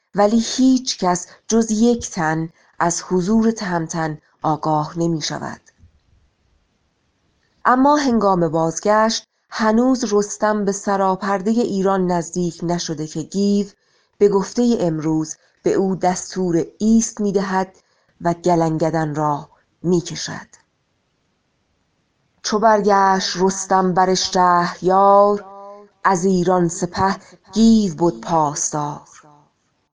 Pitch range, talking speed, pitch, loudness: 165-205 Hz, 100 wpm, 190 Hz, -18 LUFS